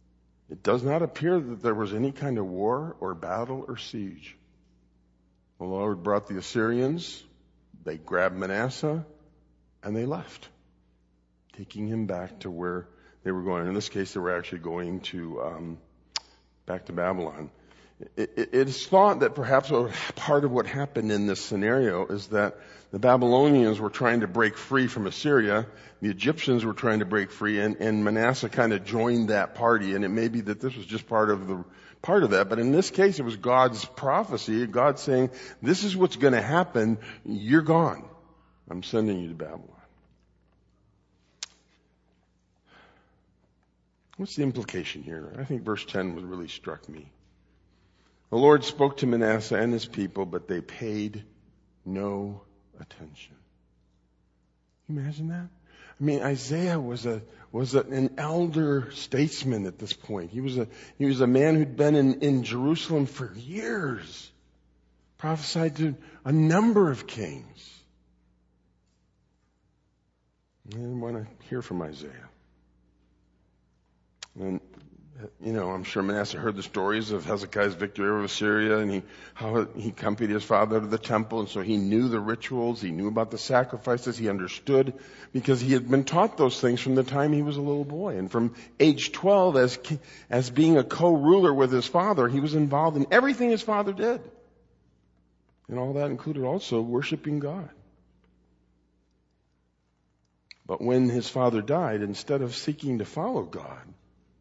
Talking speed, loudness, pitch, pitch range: 160 wpm, -26 LUFS, 110 Hz, 90-135 Hz